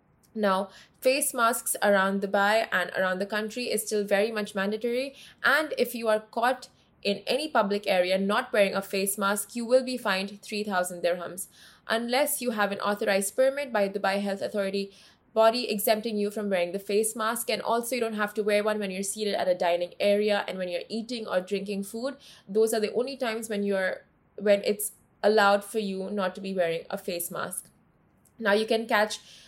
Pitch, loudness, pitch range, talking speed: 205 Hz, -27 LUFS, 195-225 Hz, 200 wpm